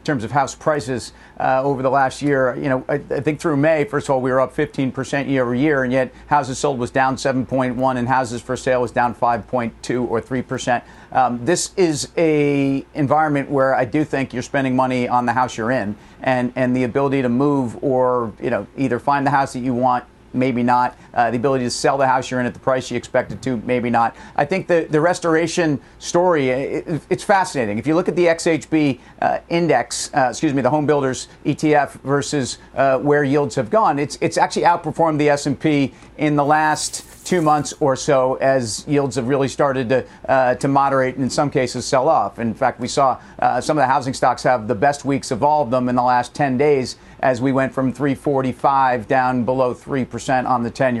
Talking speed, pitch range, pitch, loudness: 220 wpm, 125-145 Hz, 135 Hz, -19 LUFS